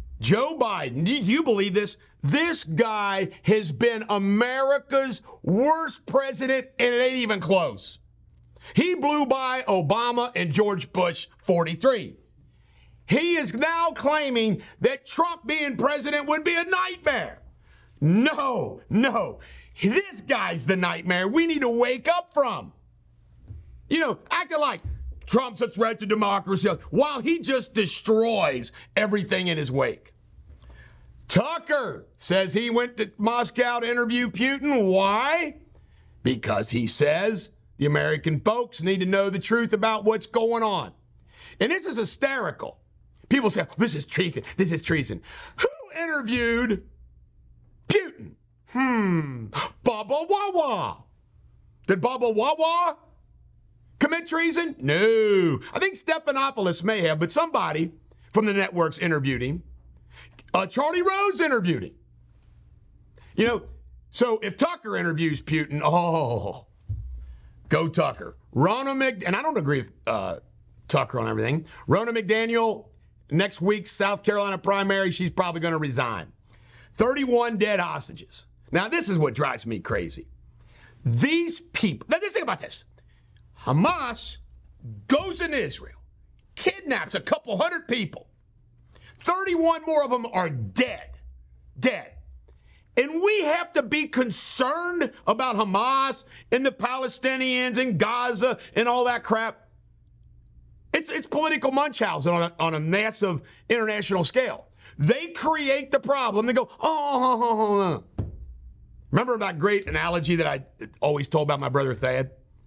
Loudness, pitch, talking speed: -24 LUFS, 210 Hz, 130 wpm